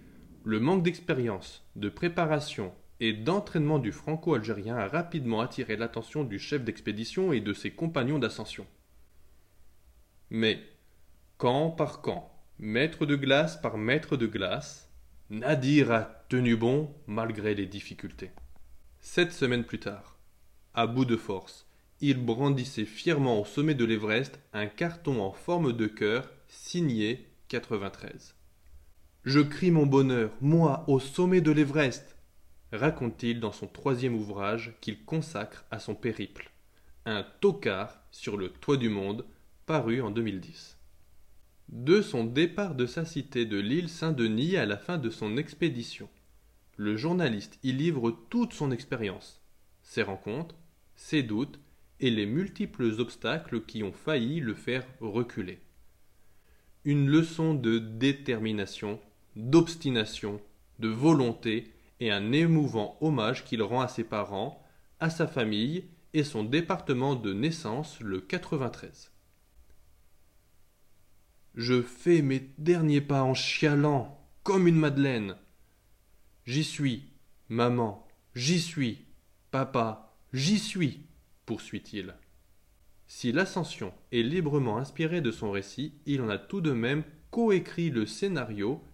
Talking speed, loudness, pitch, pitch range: 130 wpm, -30 LUFS, 115 Hz, 100-150 Hz